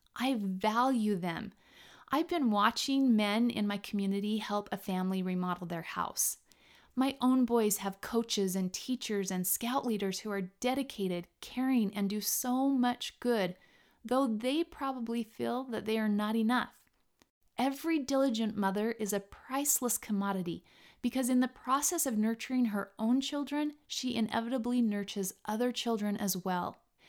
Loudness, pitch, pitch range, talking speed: -33 LUFS, 230 Hz, 200-255 Hz, 150 wpm